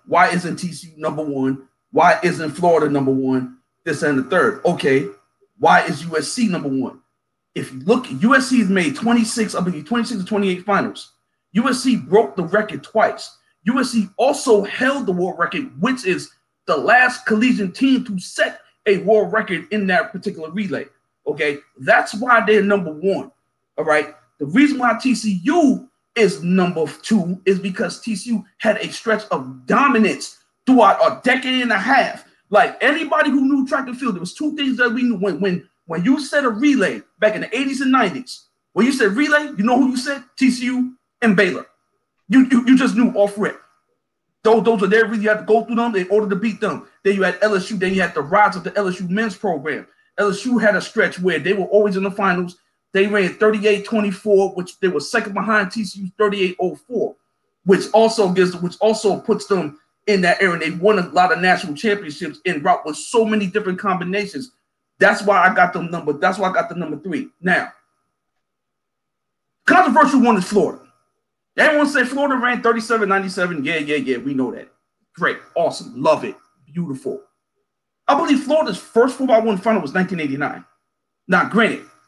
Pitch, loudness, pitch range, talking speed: 205 Hz, -18 LUFS, 180-235 Hz, 185 wpm